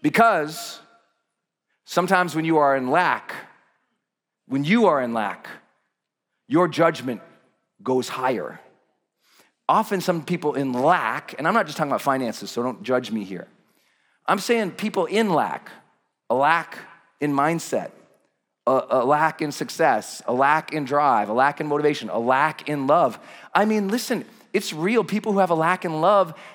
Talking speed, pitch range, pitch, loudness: 160 wpm, 145-205 Hz, 165 Hz, -22 LUFS